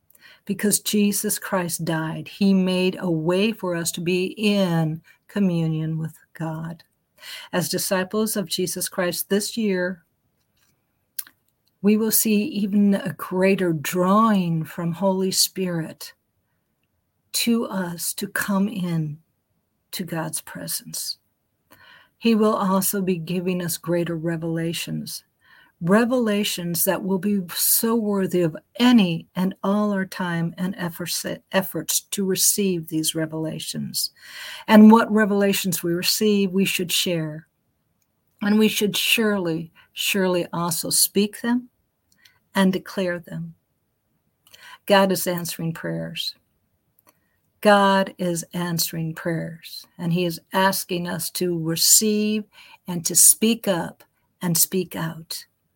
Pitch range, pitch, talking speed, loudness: 170-200 Hz, 185 Hz, 115 wpm, -21 LUFS